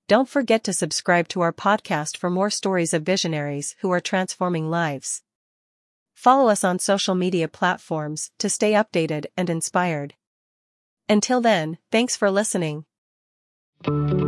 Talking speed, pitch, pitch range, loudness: 135 wpm, 180 Hz, 160-205 Hz, -22 LUFS